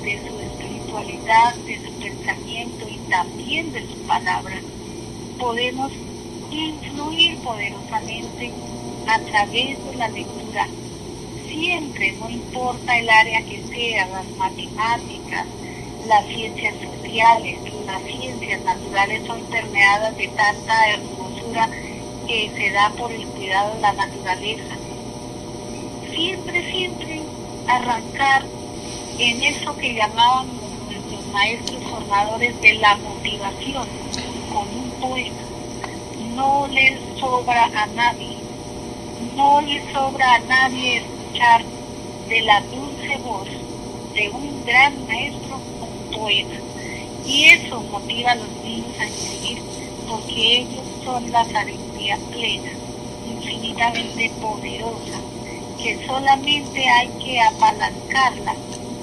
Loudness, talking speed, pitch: -20 LUFS, 105 wpm, 225 Hz